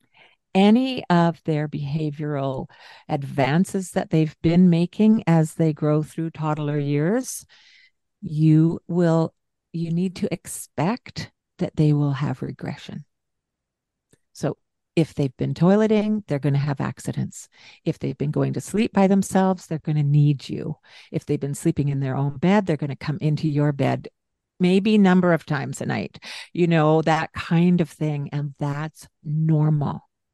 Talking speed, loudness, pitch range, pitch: 155 wpm, -22 LUFS, 145-180 Hz, 155 Hz